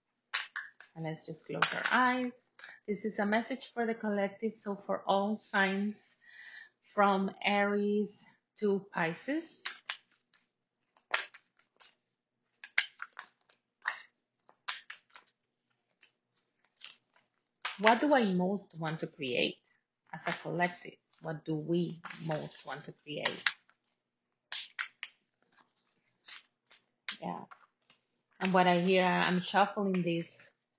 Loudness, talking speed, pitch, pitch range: -33 LUFS, 90 wpm, 195 Hz, 170-215 Hz